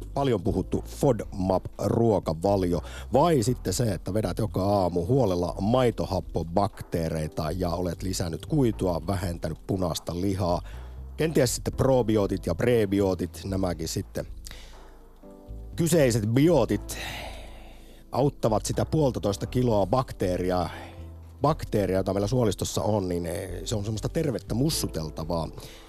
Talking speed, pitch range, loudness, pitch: 100 wpm, 85-115 Hz, -26 LUFS, 100 Hz